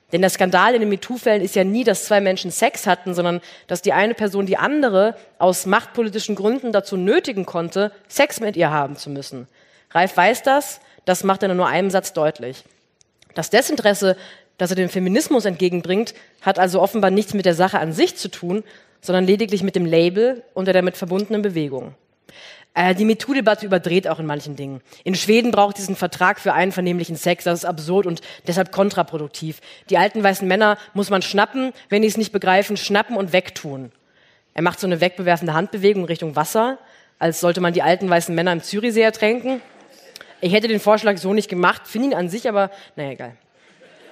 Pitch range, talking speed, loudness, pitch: 175-210 Hz, 190 wpm, -19 LUFS, 190 Hz